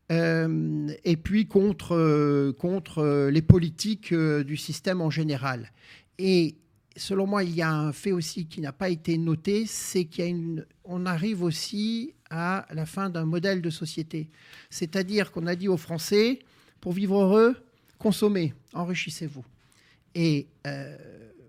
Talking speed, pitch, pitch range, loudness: 145 wpm, 170 Hz, 155-190 Hz, -26 LUFS